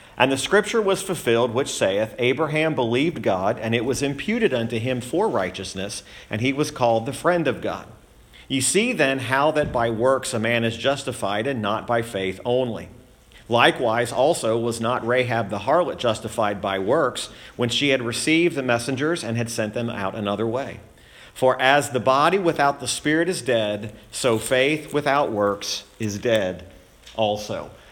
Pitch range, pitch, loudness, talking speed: 110-140 Hz, 120 Hz, -22 LUFS, 175 wpm